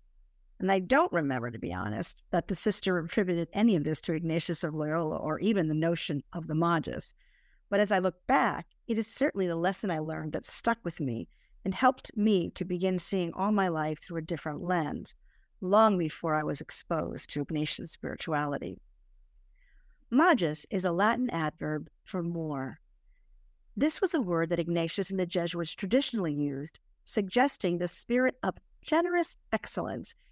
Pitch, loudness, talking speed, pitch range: 180 Hz, -30 LUFS, 170 wpm, 160-215 Hz